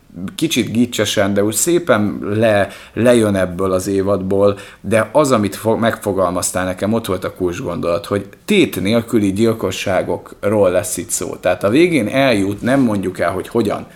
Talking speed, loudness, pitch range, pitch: 155 wpm, -16 LUFS, 100-115 Hz, 105 Hz